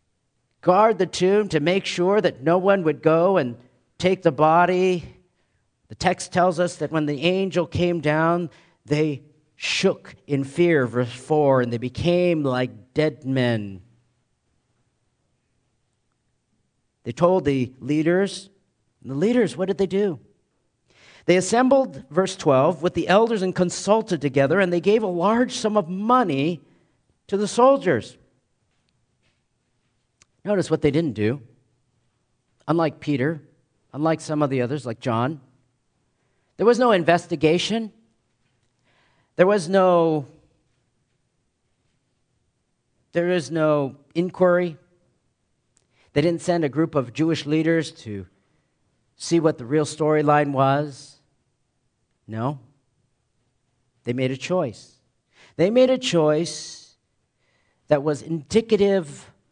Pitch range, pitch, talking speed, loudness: 125-180 Hz, 155 Hz, 120 wpm, -21 LUFS